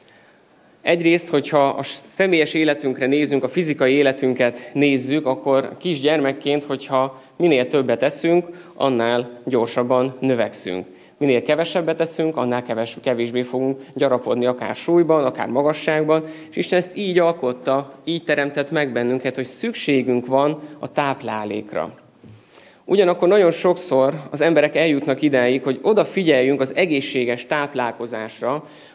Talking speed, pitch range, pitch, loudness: 115 wpm, 125-155 Hz, 135 Hz, -20 LUFS